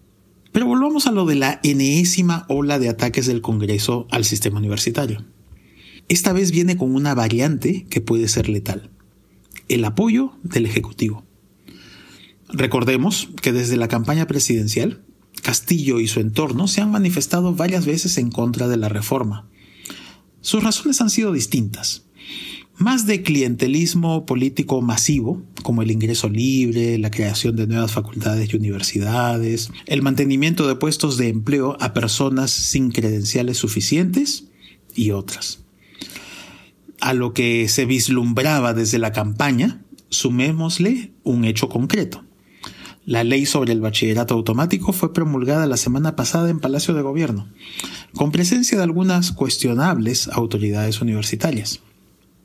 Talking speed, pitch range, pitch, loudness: 135 wpm, 115-160 Hz, 130 Hz, -19 LUFS